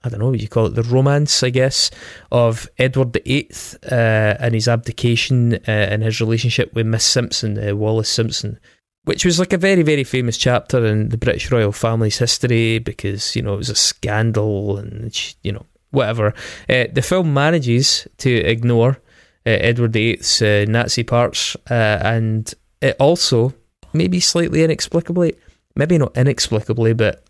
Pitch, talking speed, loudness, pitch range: 115 Hz, 165 wpm, -17 LUFS, 110-130 Hz